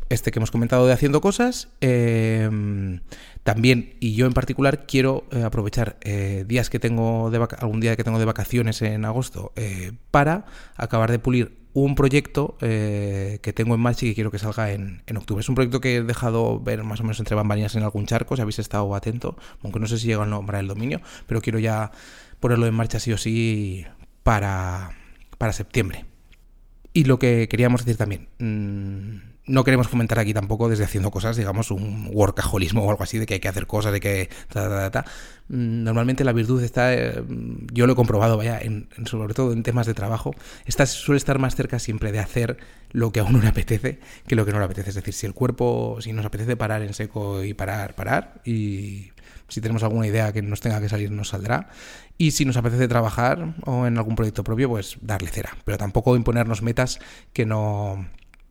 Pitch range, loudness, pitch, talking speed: 105-120 Hz, -23 LUFS, 110 Hz, 210 wpm